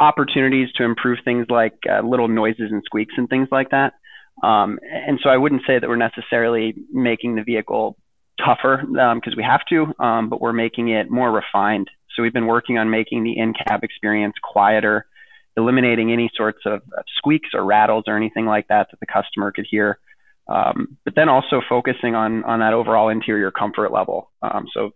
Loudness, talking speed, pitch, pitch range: -19 LUFS, 190 wpm, 115 Hz, 110-130 Hz